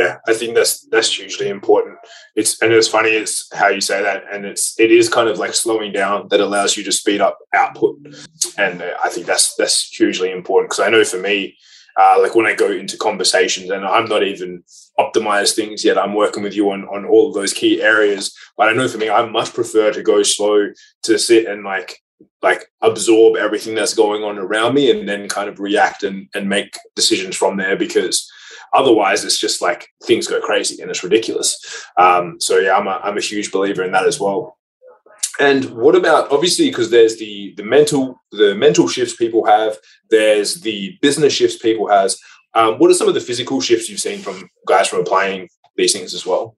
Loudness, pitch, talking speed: -15 LUFS, 385 Hz, 215 wpm